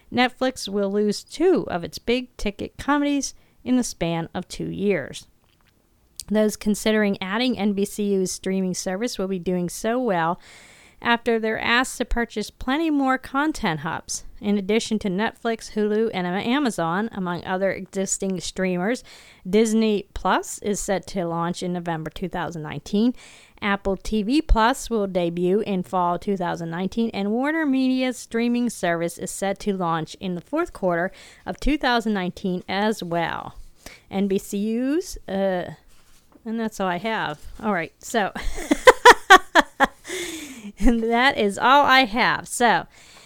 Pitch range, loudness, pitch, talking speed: 185-245 Hz, -22 LUFS, 210 Hz, 135 wpm